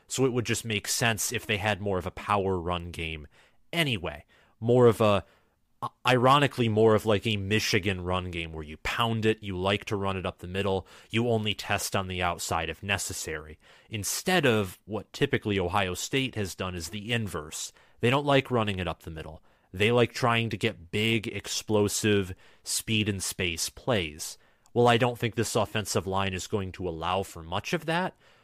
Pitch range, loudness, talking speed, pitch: 90-115 Hz, -28 LUFS, 195 wpm, 105 Hz